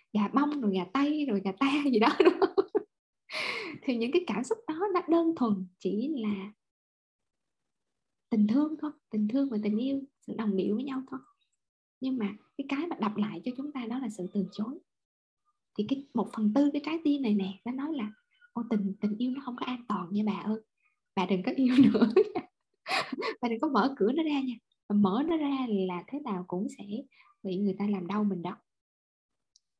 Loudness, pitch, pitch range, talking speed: -30 LUFS, 245 Hz, 205-290 Hz, 210 wpm